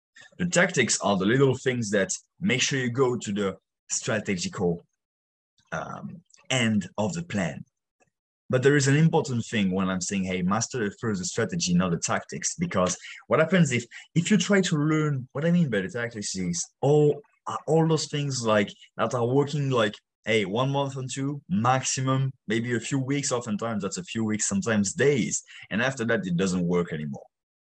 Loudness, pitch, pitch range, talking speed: -26 LUFS, 125 Hz, 100-145 Hz, 185 wpm